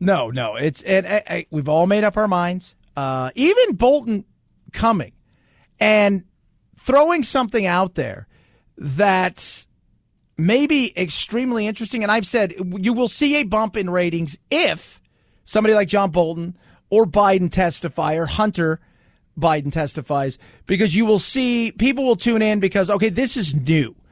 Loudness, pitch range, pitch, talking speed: -19 LUFS, 165-225 Hz, 195 Hz, 150 wpm